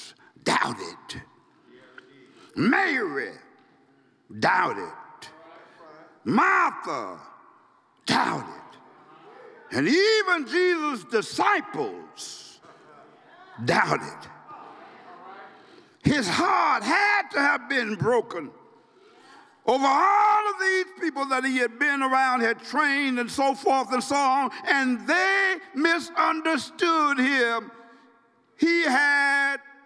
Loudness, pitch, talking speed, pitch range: -23 LUFS, 300 Hz, 80 wpm, 265-390 Hz